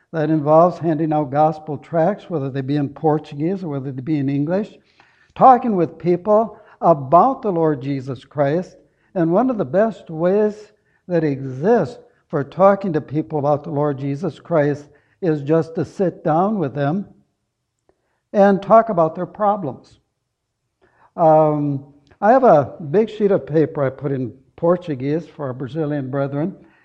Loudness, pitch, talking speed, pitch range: -19 LUFS, 155 Hz, 155 wpm, 145-180 Hz